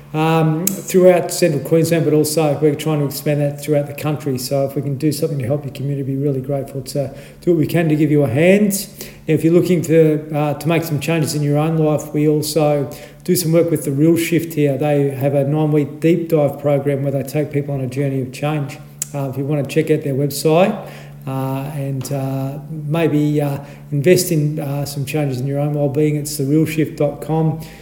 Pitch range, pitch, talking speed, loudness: 140-160 Hz, 150 Hz, 220 wpm, -17 LUFS